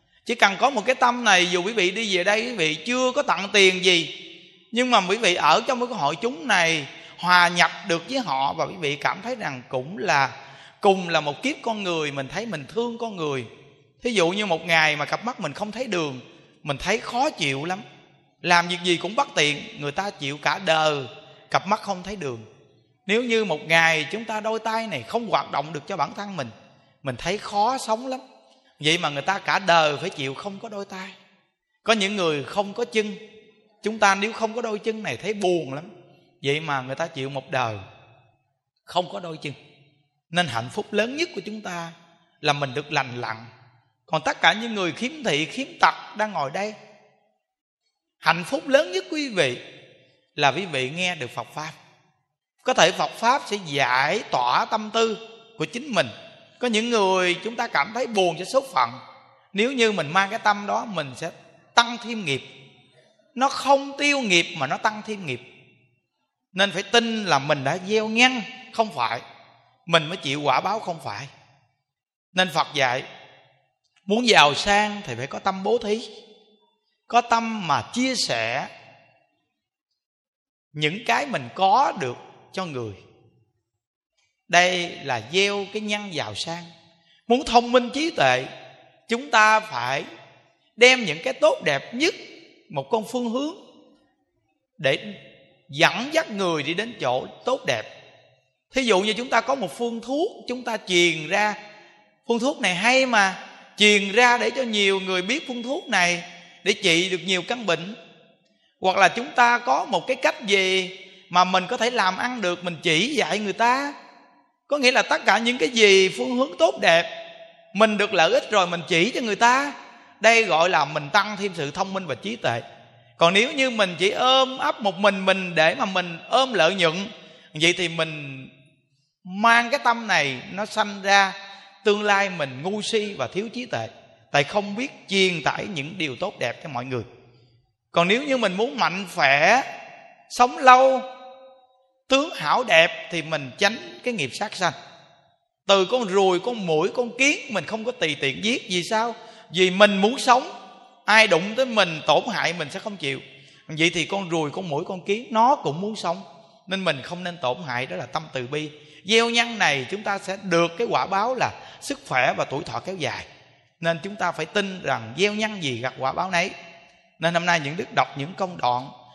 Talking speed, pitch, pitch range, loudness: 195 wpm, 190 Hz, 155-225 Hz, -22 LUFS